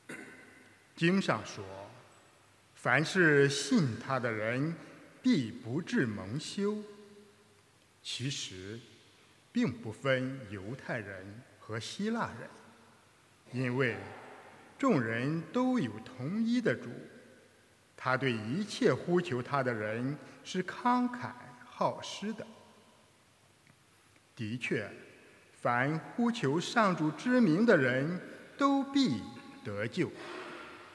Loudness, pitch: -32 LUFS, 135 Hz